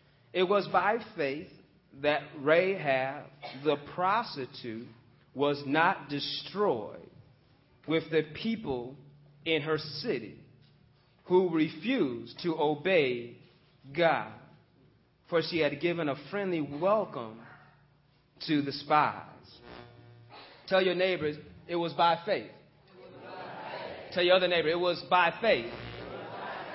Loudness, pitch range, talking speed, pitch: -30 LUFS, 140-175 Hz, 105 wpm, 150 Hz